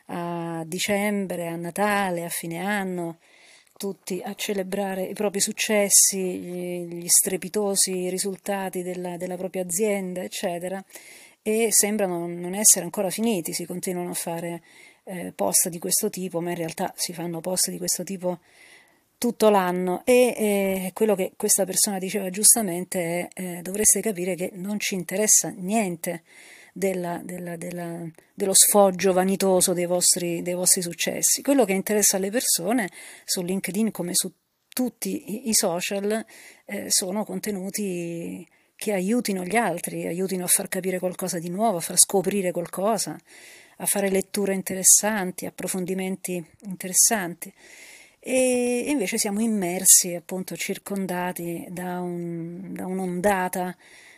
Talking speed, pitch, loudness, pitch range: 135 wpm, 185 Hz, -23 LUFS, 180-205 Hz